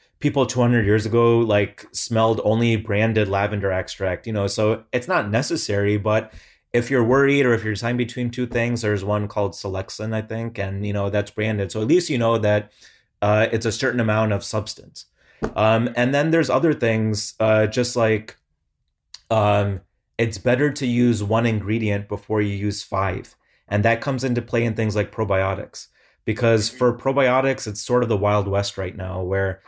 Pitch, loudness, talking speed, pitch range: 110 Hz, -21 LUFS, 185 wpm, 105-120 Hz